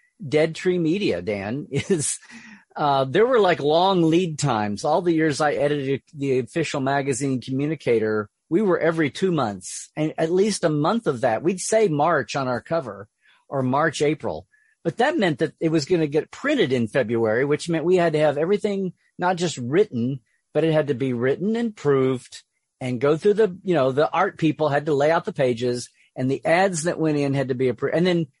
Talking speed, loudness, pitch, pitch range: 210 wpm, -22 LUFS, 155 Hz, 135-175 Hz